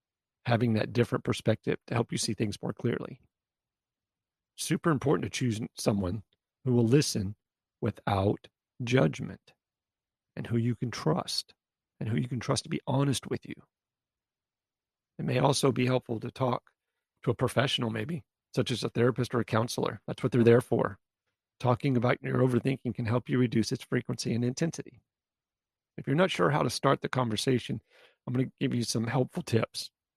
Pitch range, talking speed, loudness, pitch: 110-130 Hz, 175 wpm, -30 LUFS, 120 Hz